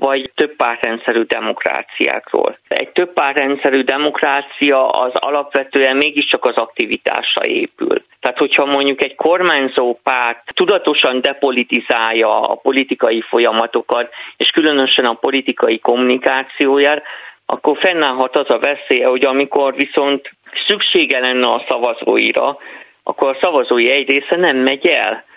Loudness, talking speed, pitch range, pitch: -14 LUFS, 120 wpm, 125-140 Hz, 135 Hz